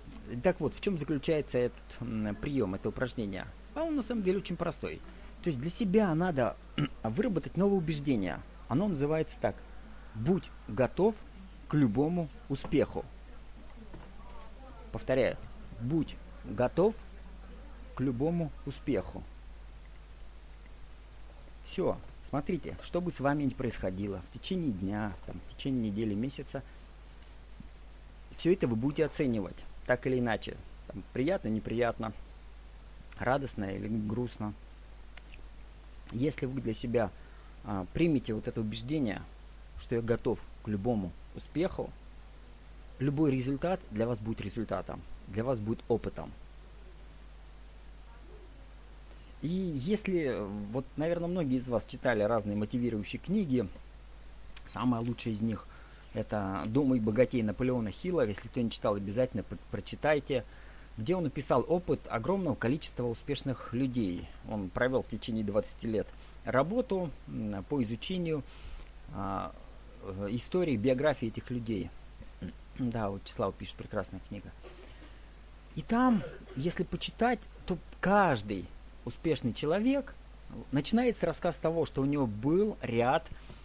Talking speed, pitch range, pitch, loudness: 120 wpm, 105-155 Hz, 120 Hz, -33 LUFS